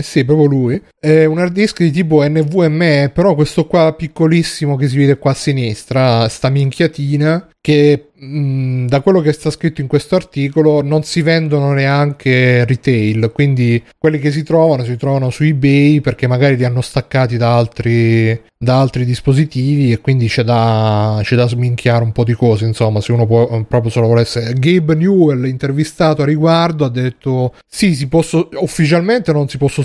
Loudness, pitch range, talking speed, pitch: -13 LUFS, 125-155 Hz, 175 wpm, 140 Hz